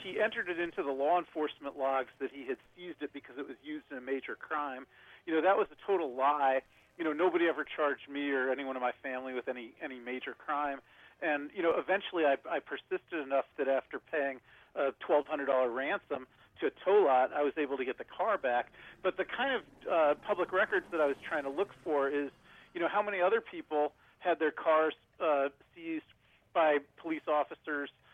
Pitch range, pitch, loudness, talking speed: 135-170 Hz, 145 Hz, -33 LUFS, 210 wpm